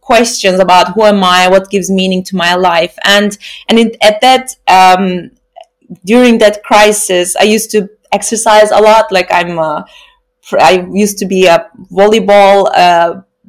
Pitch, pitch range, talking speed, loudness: 205 Hz, 185-220 Hz, 160 wpm, -8 LUFS